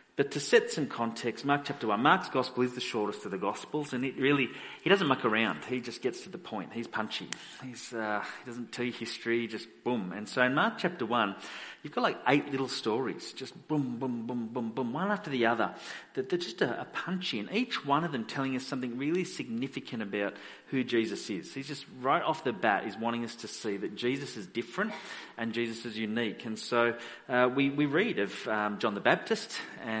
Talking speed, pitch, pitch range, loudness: 220 wpm, 125 Hz, 115-140 Hz, -32 LUFS